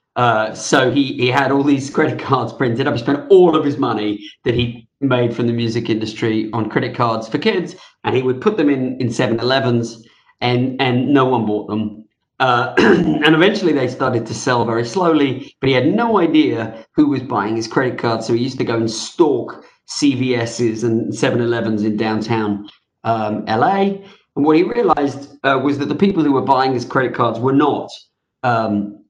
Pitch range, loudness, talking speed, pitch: 115-140 Hz, -17 LUFS, 195 wpm, 125 Hz